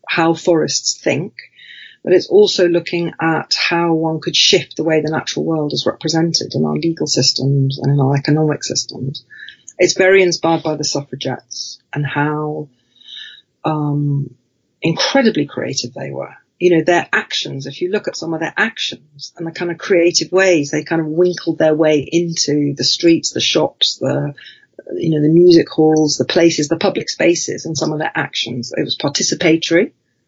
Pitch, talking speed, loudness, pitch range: 160 Hz, 175 wpm, -15 LUFS, 145-170 Hz